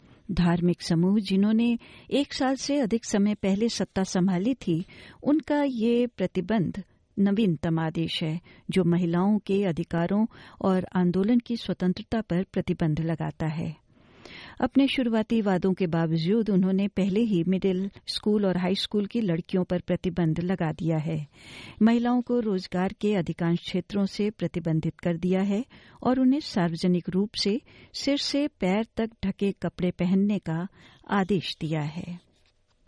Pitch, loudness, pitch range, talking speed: 190 Hz, -26 LUFS, 175-215 Hz, 140 wpm